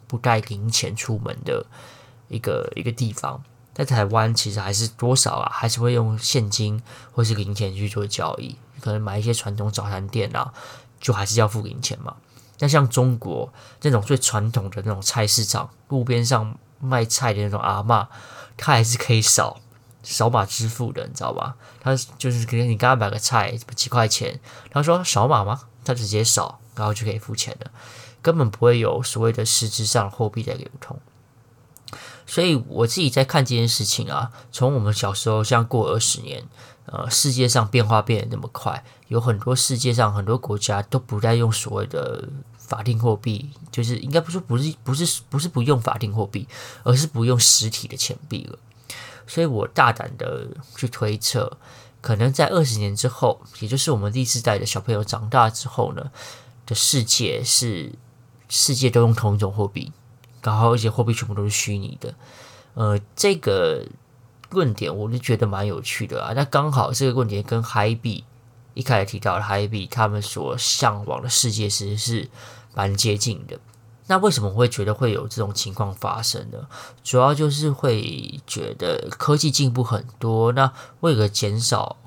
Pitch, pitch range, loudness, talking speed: 120 Hz, 110-130 Hz, -21 LUFS, 270 characters per minute